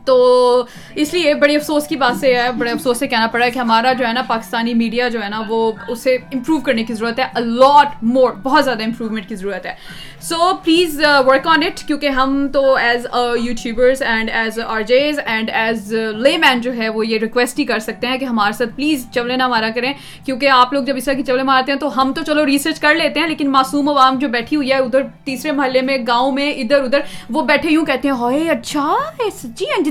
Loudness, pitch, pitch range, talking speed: -15 LUFS, 260 Hz, 235-290 Hz, 235 wpm